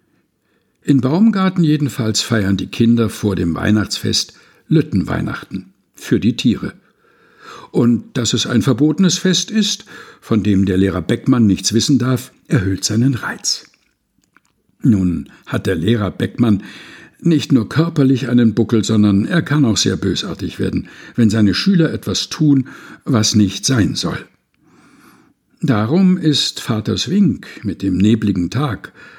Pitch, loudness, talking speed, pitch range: 115 Hz, -16 LUFS, 135 wpm, 105-145 Hz